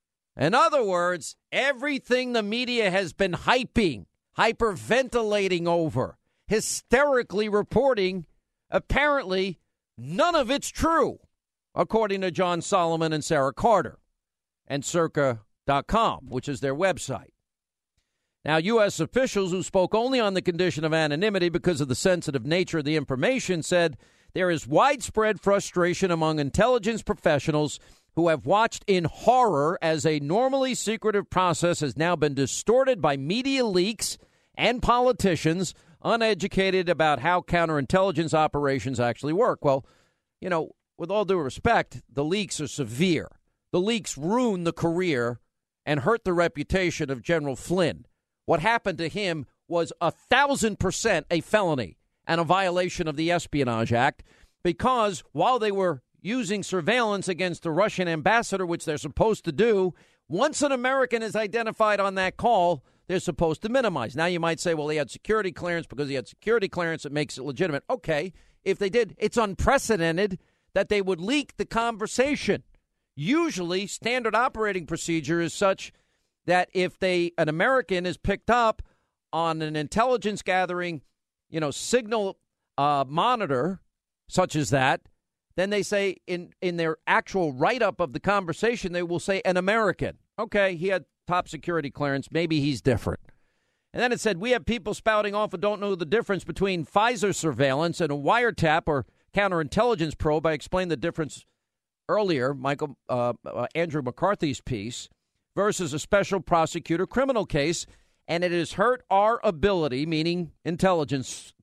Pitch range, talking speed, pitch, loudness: 155-210 Hz, 150 wpm, 180 Hz, -25 LUFS